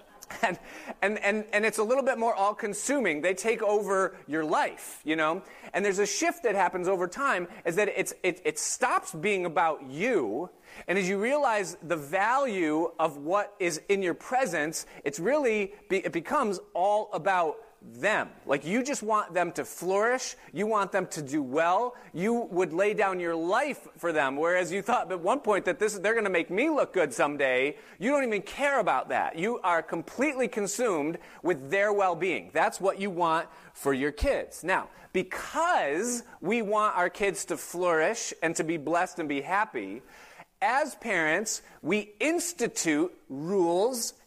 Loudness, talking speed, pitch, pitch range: -28 LUFS, 180 wpm, 195 Hz, 170-220 Hz